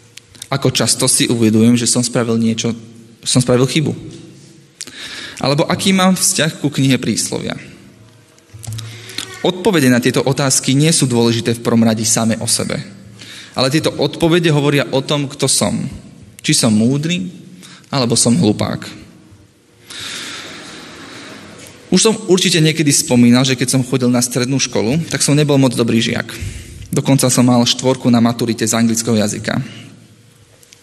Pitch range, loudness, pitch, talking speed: 115-145 Hz, -14 LUFS, 125 Hz, 140 wpm